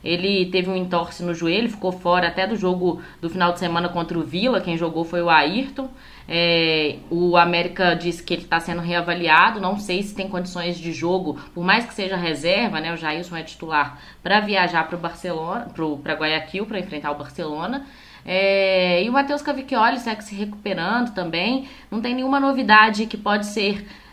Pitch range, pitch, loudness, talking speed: 170-210 Hz, 180 Hz, -21 LUFS, 185 wpm